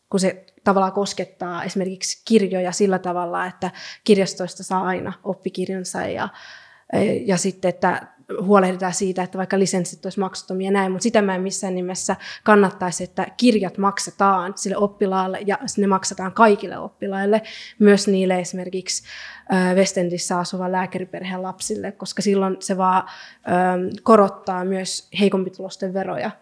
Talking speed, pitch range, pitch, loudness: 130 wpm, 185-200 Hz, 190 Hz, -21 LUFS